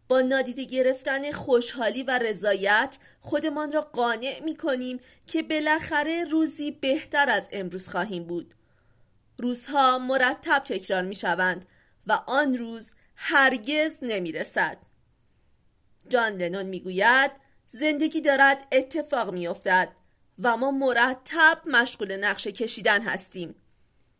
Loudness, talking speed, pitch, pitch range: -23 LUFS, 115 wpm, 255 Hz, 205-285 Hz